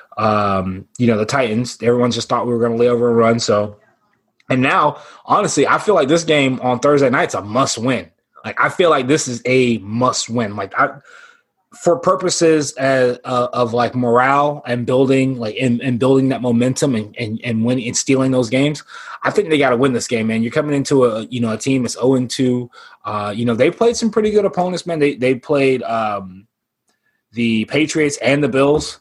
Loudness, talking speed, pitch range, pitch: -16 LUFS, 215 wpm, 115-145 Hz, 125 Hz